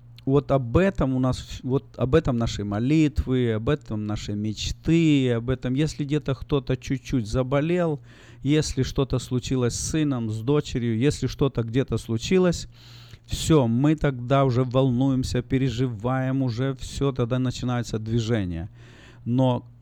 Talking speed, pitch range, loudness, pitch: 135 wpm, 120-140 Hz, -24 LUFS, 130 Hz